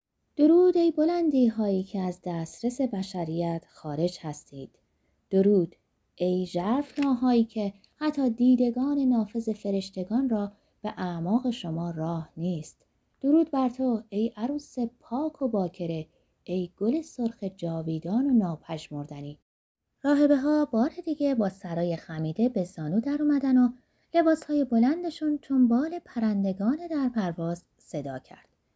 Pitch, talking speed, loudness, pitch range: 225 Hz, 130 wpm, -27 LUFS, 175-270 Hz